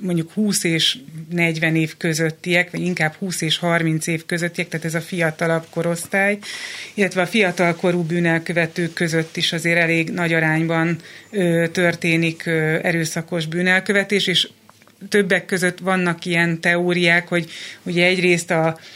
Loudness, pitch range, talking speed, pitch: -19 LUFS, 165-180 Hz, 135 wpm, 170 Hz